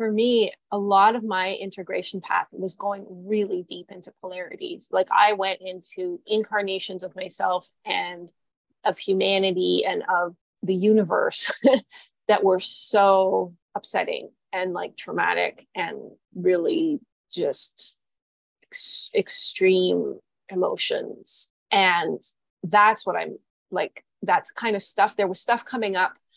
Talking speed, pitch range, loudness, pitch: 125 wpm, 185-230 Hz, -24 LUFS, 195 Hz